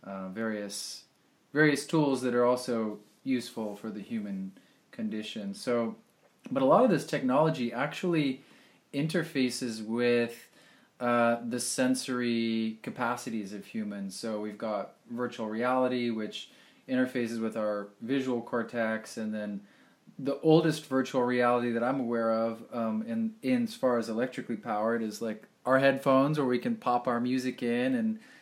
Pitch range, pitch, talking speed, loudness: 110-135 Hz, 120 Hz, 150 wpm, -30 LUFS